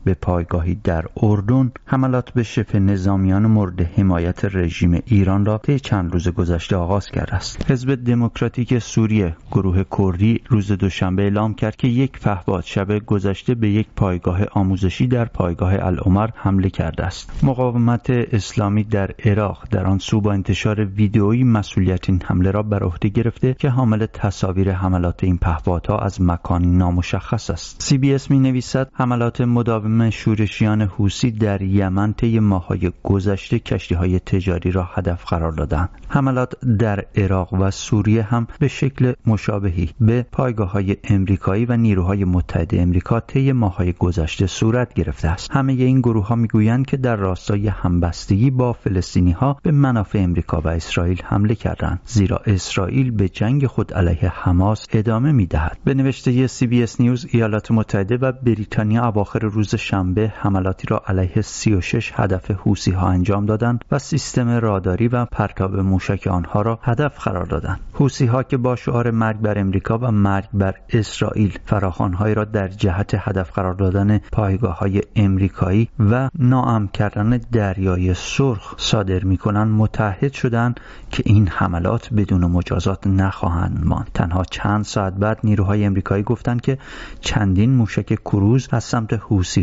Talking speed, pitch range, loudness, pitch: 150 wpm, 95-115 Hz, -19 LUFS, 105 Hz